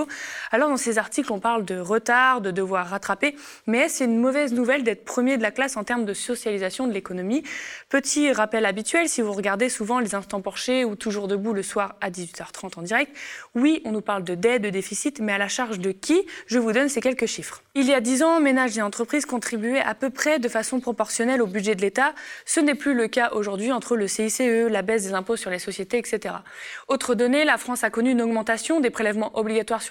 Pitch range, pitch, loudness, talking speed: 210-260 Hz, 230 Hz, -23 LUFS, 230 wpm